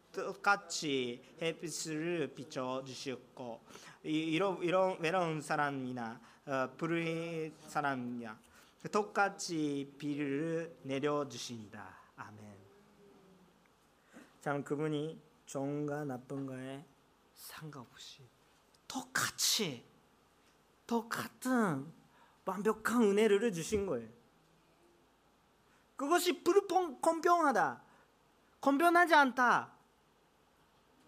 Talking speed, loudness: 170 characters per minute, -34 LUFS